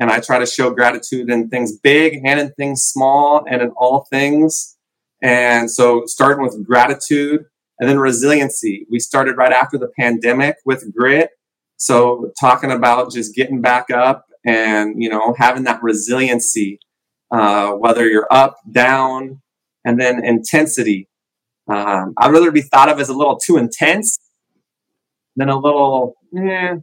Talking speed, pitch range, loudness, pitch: 155 wpm, 120-140 Hz, -14 LUFS, 125 Hz